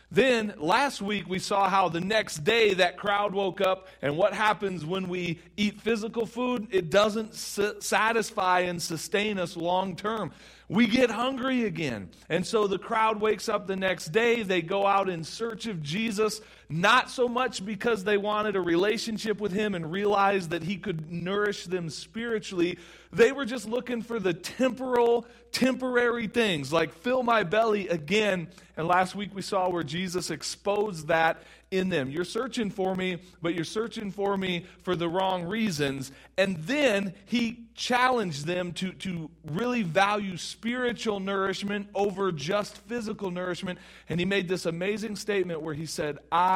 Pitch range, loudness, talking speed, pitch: 180-220 Hz, -28 LUFS, 170 wpm, 200 Hz